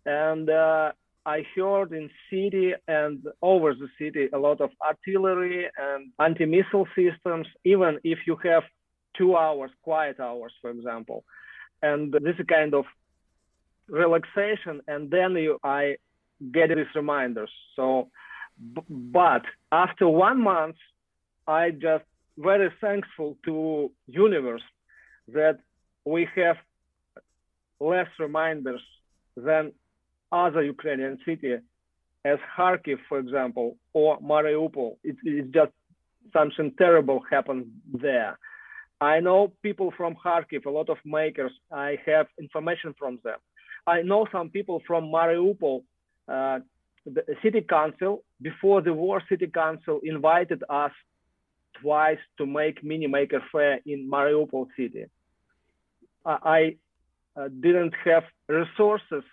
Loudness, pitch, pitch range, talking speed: -25 LUFS, 155 Hz, 140-175 Hz, 120 wpm